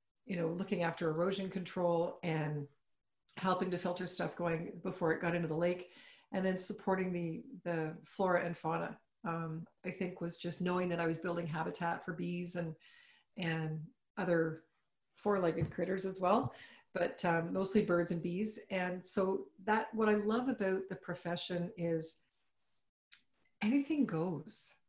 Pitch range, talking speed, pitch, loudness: 170-190 Hz, 155 wpm, 175 Hz, -37 LUFS